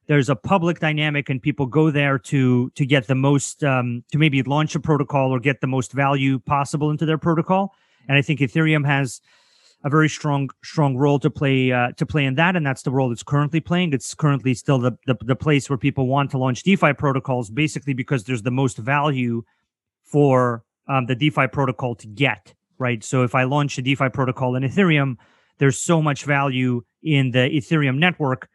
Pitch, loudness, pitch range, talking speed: 140 Hz, -20 LUFS, 130-150 Hz, 205 wpm